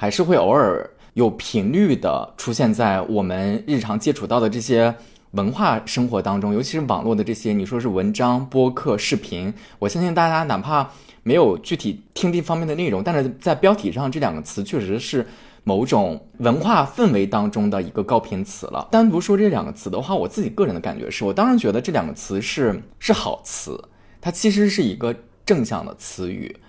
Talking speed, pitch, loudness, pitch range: 300 characters per minute, 120 Hz, -21 LUFS, 105-175 Hz